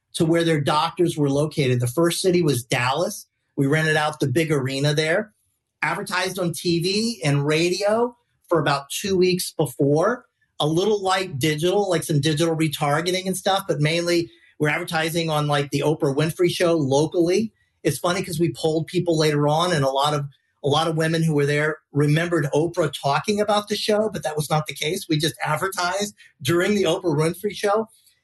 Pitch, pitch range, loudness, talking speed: 160 Hz, 150-180 Hz, -22 LUFS, 185 wpm